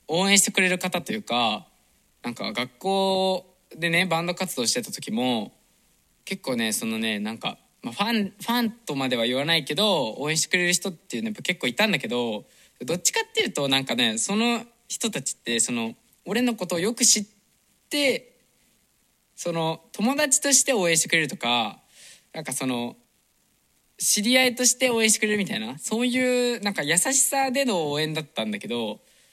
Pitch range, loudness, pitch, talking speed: 165-235 Hz, -23 LUFS, 205 Hz, 350 characters per minute